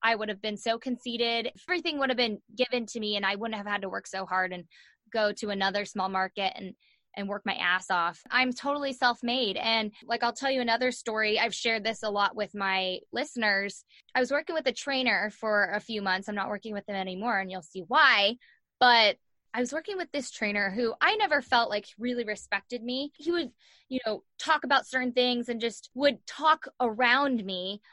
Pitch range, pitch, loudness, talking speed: 205-250 Hz, 225 Hz, -28 LUFS, 215 wpm